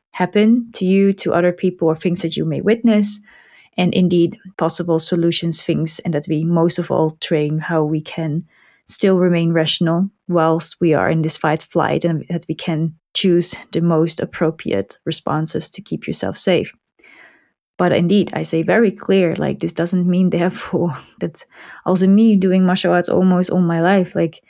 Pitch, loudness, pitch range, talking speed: 170 Hz, -17 LUFS, 160-185 Hz, 175 wpm